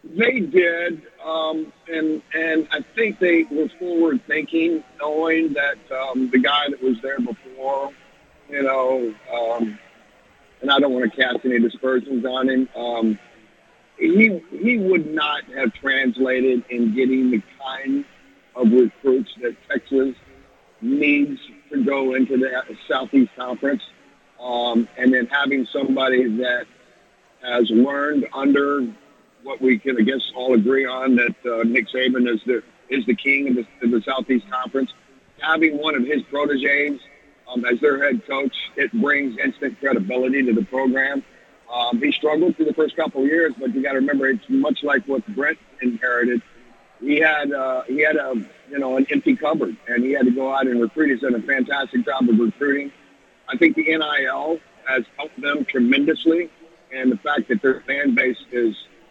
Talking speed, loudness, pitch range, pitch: 170 wpm, -20 LUFS, 125-155 Hz, 135 Hz